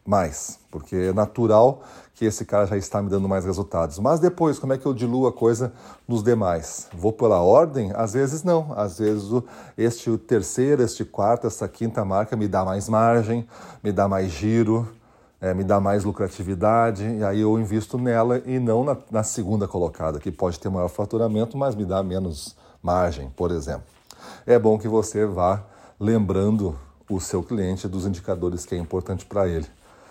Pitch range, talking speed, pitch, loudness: 95-115 Hz, 185 wpm, 105 Hz, -23 LUFS